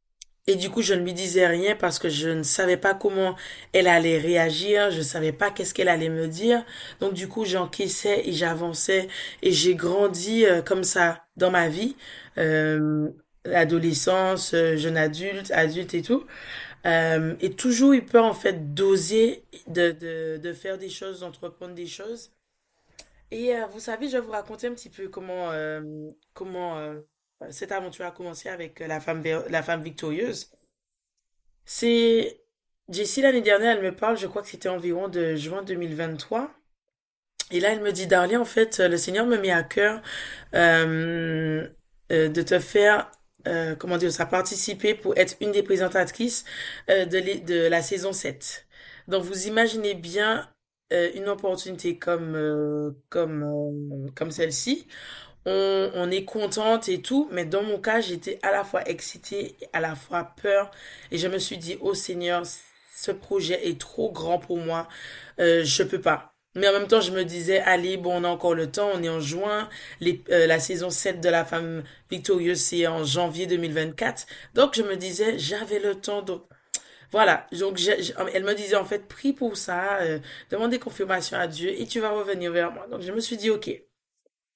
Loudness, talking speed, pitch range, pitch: -23 LUFS, 185 wpm, 170-210 Hz, 185 Hz